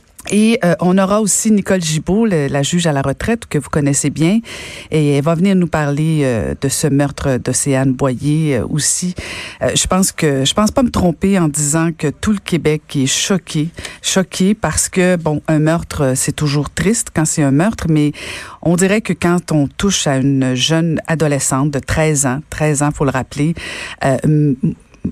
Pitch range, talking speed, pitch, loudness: 140-180 Hz, 195 wpm, 155 Hz, -15 LUFS